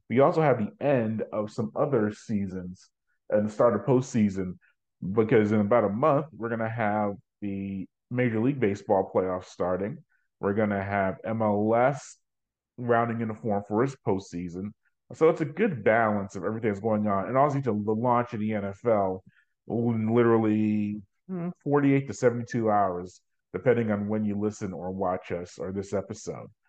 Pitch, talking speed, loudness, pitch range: 110 Hz, 155 wpm, -27 LUFS, 100-120 Hz